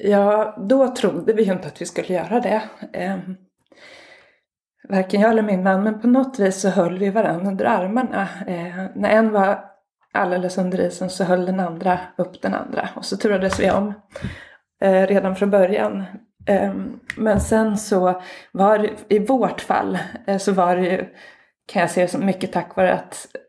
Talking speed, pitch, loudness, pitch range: 170 wpm, 195 Hz, -20 LUFS, 185-215 Hz